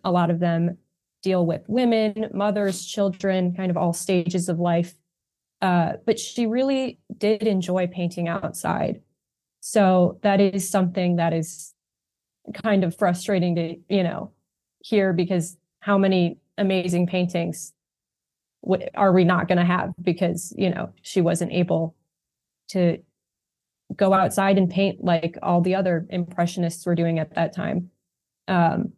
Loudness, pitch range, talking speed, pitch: -23 LUFS, 175-195 Hz, 145 wpm, 180 Hz